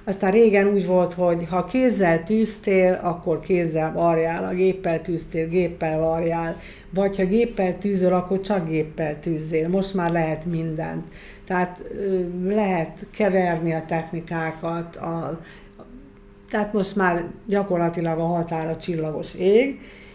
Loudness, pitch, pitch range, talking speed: -23 LUFS, 175 Hz, 165-195 Hz, 125 wpm